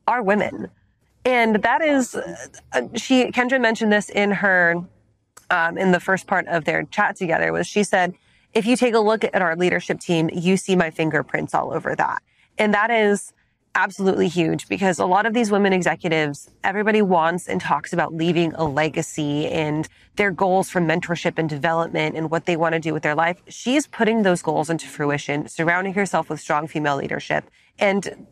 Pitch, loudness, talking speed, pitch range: 180 Hz, -21 LUFS, 185 wpm, 160-205 Hz